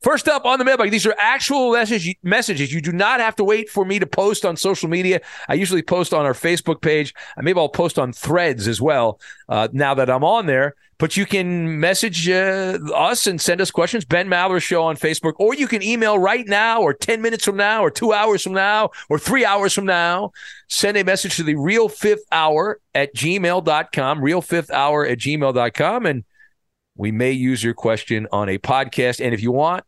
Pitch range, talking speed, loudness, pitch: 150-210 Hz, 215 wpm, -18 LUFS, 180 Hz